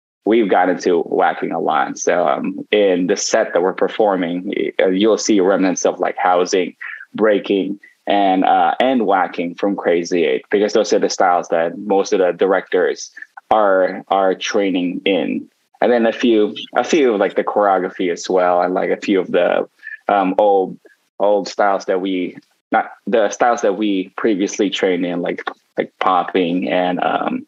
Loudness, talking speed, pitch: -17 LUFS, 175 wpm, 270 Hz